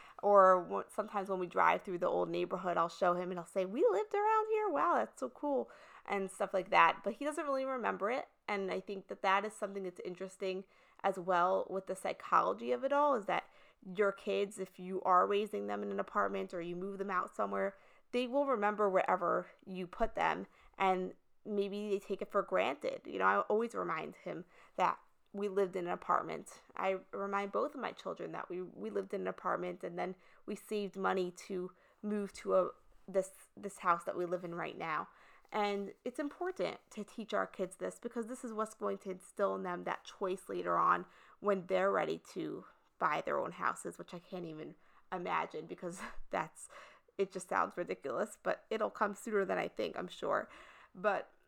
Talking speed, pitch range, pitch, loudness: 205 wpm, 185-210 Hz, 195 Hz, -36 LUFS